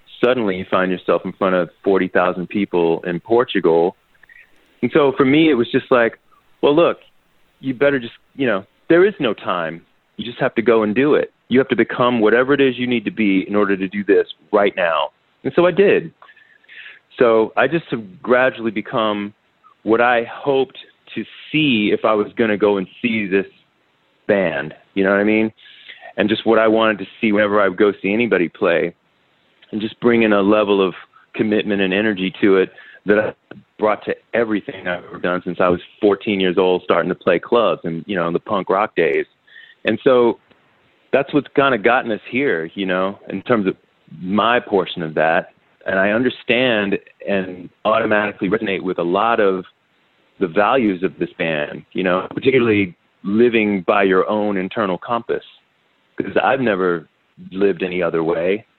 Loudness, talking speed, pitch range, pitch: -18 LUFS, 190 wpm, 95-125 Hz, 105 Hz